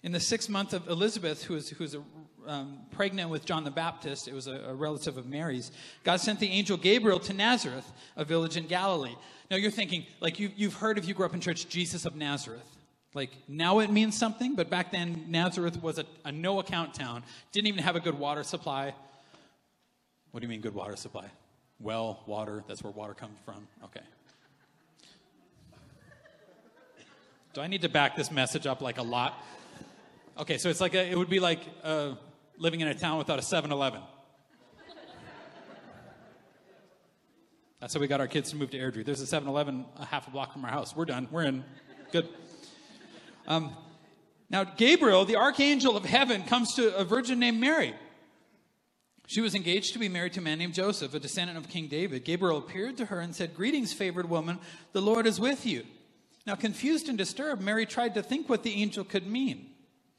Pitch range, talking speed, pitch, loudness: 145-200 Hz, 195 wpm, 165 Hz, -30 LUFS